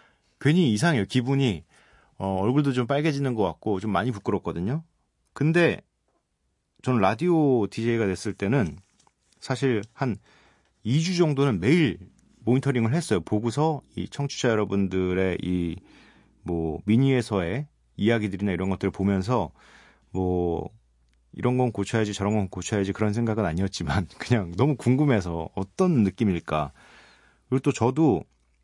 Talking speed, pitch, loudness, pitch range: 290 characters per minute, 110 Hz, -25 LUFS, 95-135 Hz